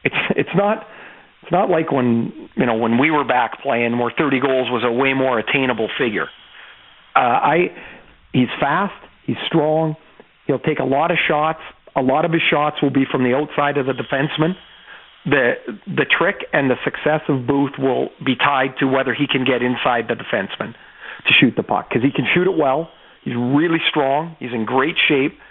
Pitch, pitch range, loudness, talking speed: 140 Hz, 130-155 Hz, -18 LUFS, 200 wpm